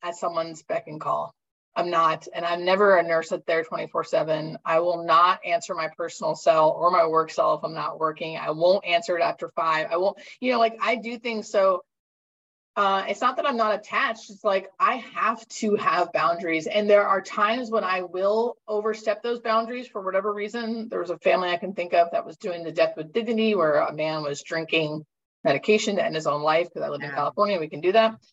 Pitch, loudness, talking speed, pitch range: 190 Hz, -24 LUFS, 225 wpm, 165-220 Hz